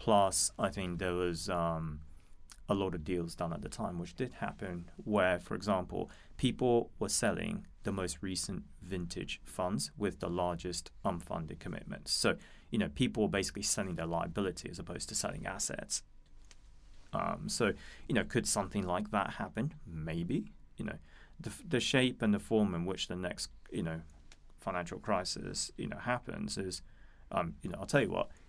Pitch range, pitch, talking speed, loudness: 80-95 Hz, 90 Hz, 175 wpm, -36 LUFS